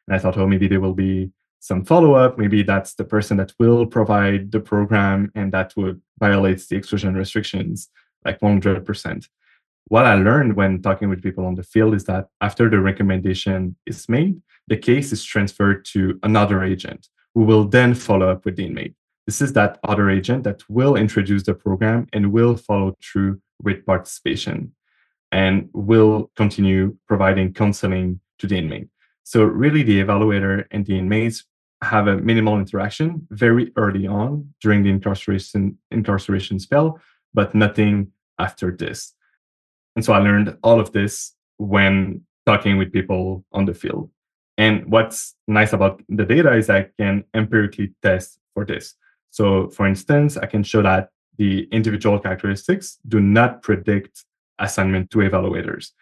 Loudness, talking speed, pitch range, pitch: -19 LUFS, 160 wpm, 95-110 Hz, 100 Hz